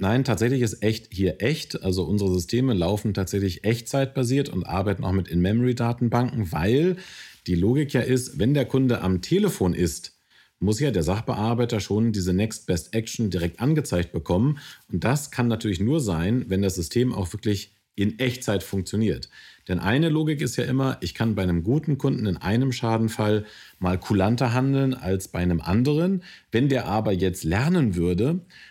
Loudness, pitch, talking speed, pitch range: -24 LUFS, 110 Hz, 170 wpm, 95-130 Hz